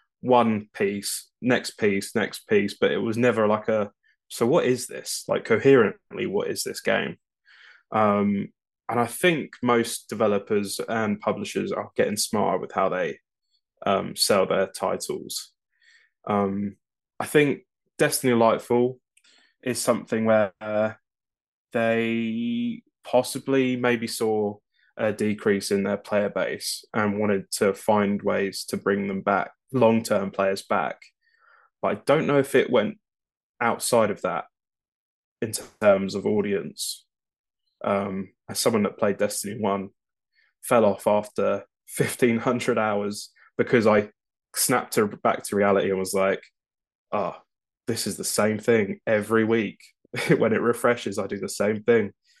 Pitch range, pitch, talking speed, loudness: 100-125 Hz, 110 Hz, 140 wpm, -24 LUFS